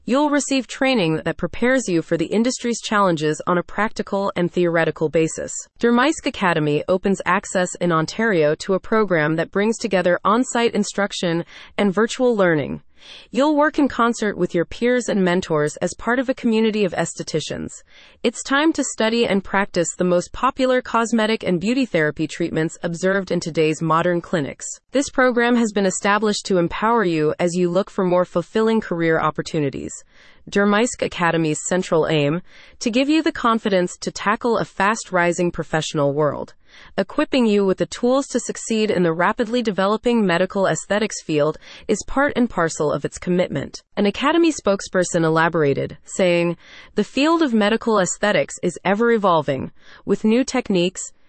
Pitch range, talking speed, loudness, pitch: 170-235 Hz, 160 wpm, -20 LUFS, 195 Hz